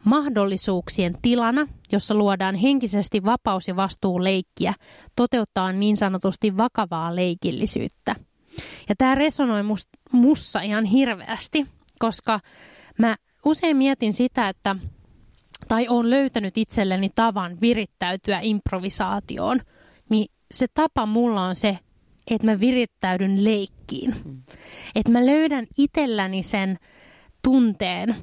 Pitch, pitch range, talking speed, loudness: 220 Hz, 195-245 Hz, 100 wpm, -22 LUFS